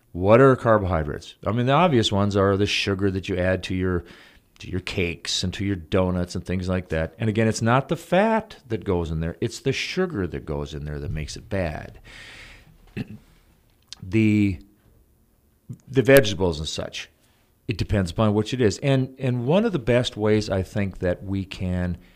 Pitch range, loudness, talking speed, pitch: 90-120 Hz, -23 LUFS, 190 wpm, 100 Hz